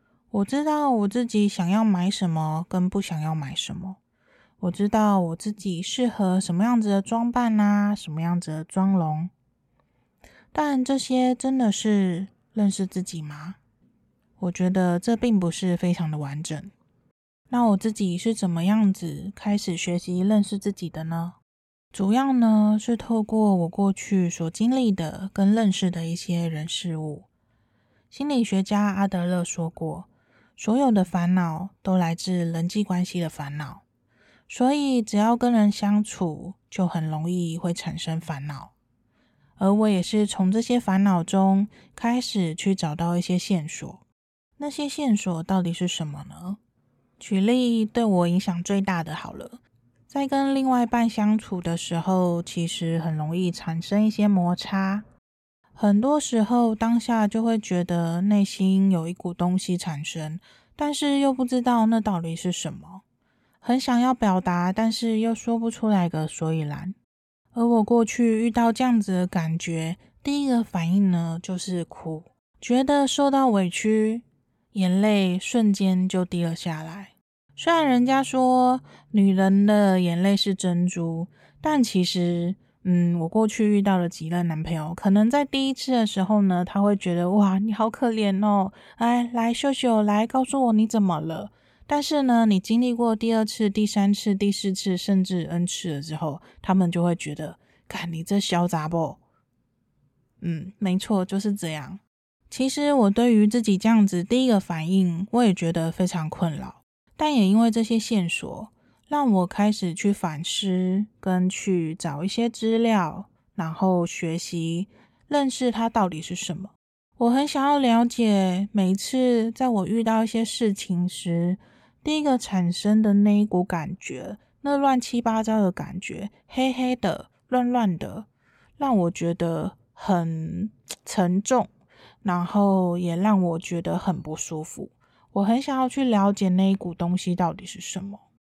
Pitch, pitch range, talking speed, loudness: 195 Hz, 175-225 Hz, 230 characters per minute, -23 LUFS